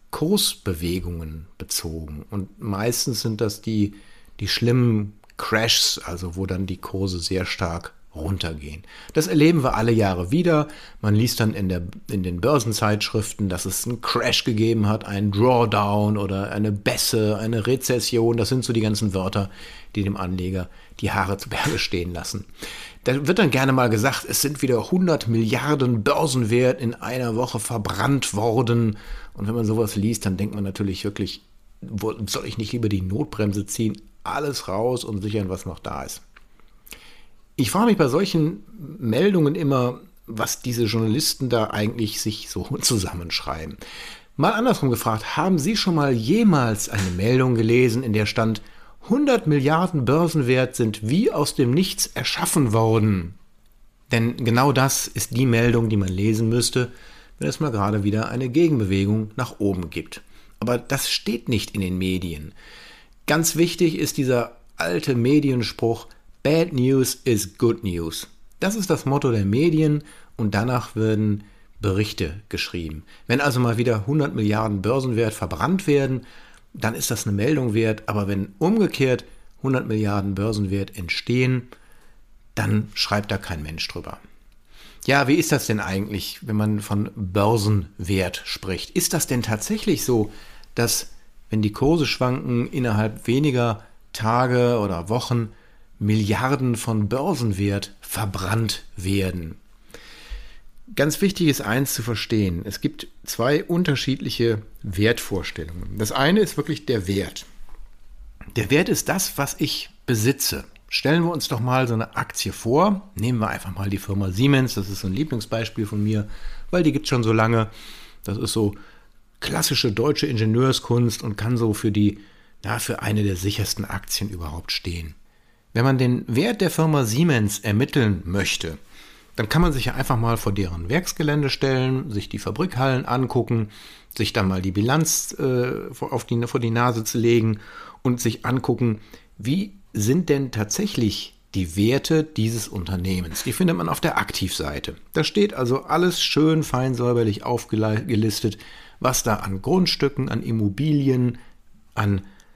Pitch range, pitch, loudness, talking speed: 105-130 Hz, 115 Hz, -22 LUFS, 155 wpm